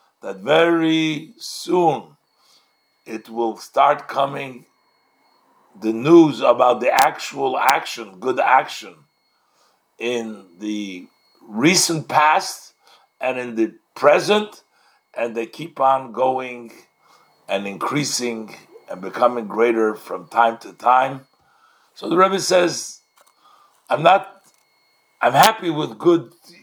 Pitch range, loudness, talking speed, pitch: 115-165 Hz, -19 LUFS, 105 wpm, 130 Hz